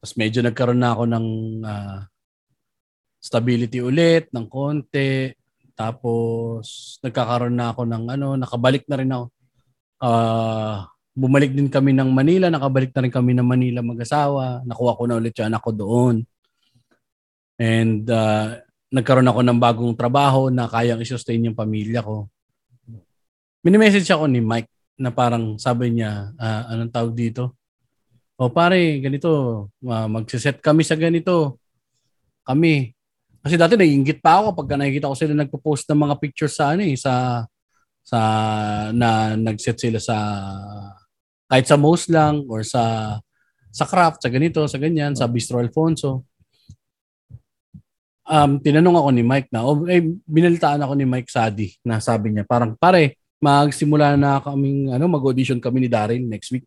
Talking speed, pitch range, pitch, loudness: 150 wpm, 115-140 Hz, 125 Hz, -19 LUFS